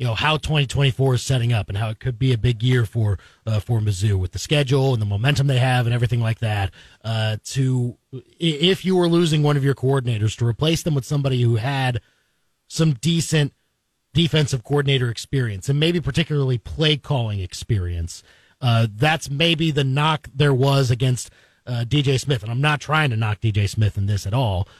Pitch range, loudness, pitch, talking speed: 110-145 Hz, -21 LUFS, 130 Hz, 200 wpm